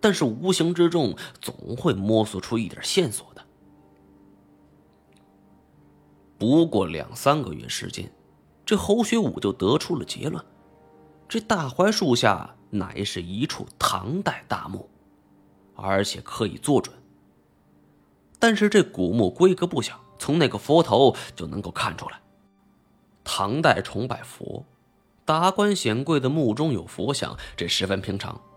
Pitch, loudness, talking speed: 100 Hz, -24 LUFS, 195 characters per minute